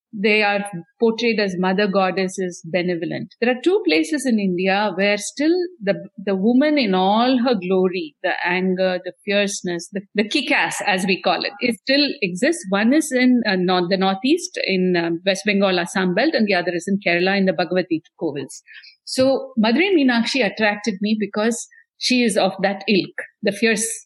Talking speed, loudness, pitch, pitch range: 180 wpm, -19 LUFS, 205 Hz, 185-245 Hz